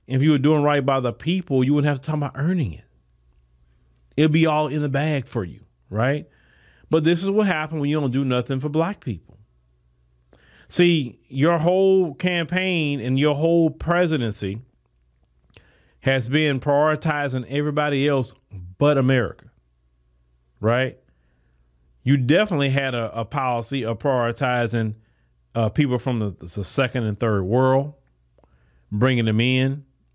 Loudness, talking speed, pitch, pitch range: -21 LUFS, 145 wpm, 130 Hz, 95-150 Hz